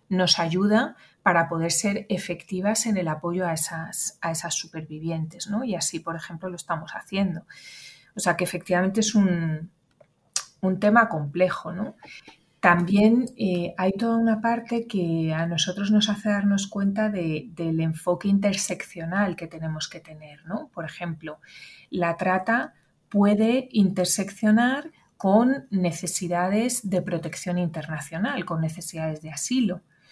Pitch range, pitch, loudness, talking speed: 165-205 Hz, 180 Hz, -24 LUFS, 135 wpm